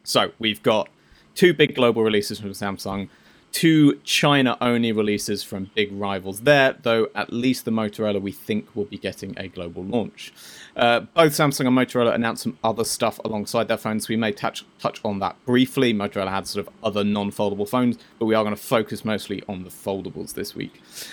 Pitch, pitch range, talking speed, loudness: 110 Hz, 100-120 Hz, 190 wpm, -22 LUFS